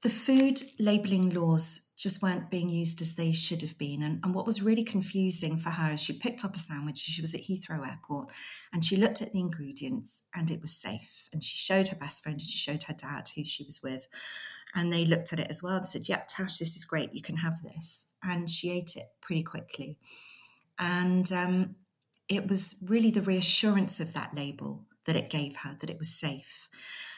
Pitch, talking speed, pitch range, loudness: 170 Hz, 220 wpm, 155-190 Hz, -24 LUFS